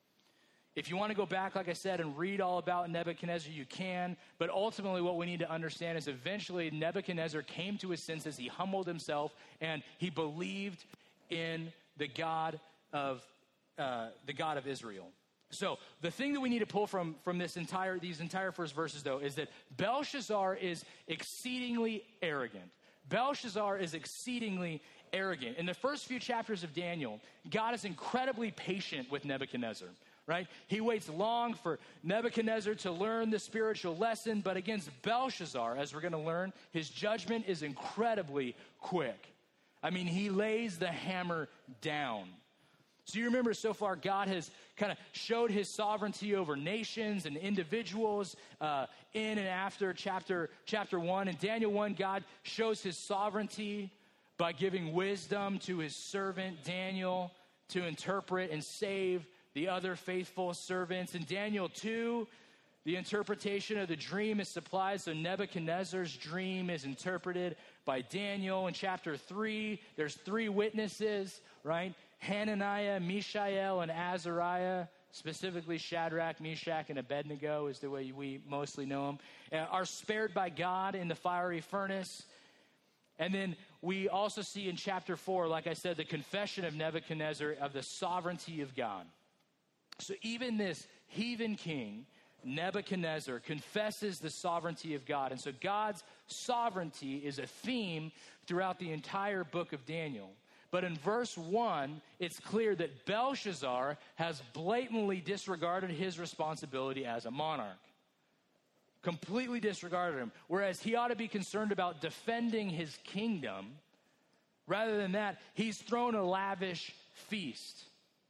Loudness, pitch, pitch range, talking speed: -38 LUFS, 185 Hz, 160-205 Hz, 145 wpm